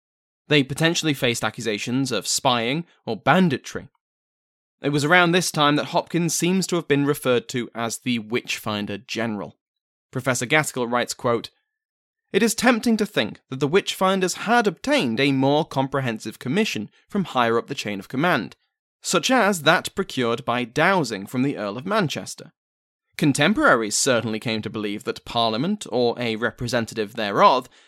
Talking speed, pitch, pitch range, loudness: 155 wpm, 135 Hz, 115-175 Hz, -22 LUFS